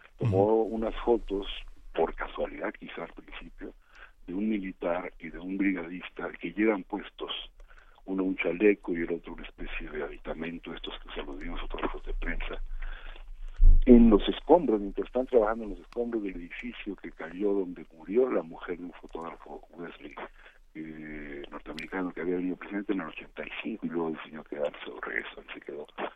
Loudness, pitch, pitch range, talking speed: -30 LUFS, 95 Hz, 85-105 Hz, 170 wpm